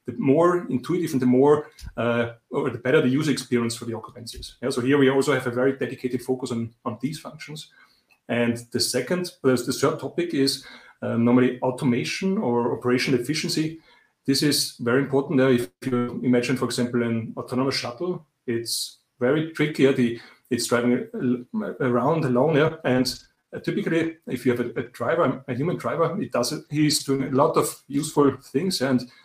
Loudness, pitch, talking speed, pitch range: -24 LUFS, 130 Hz, 180 wpm, 125-145 Hz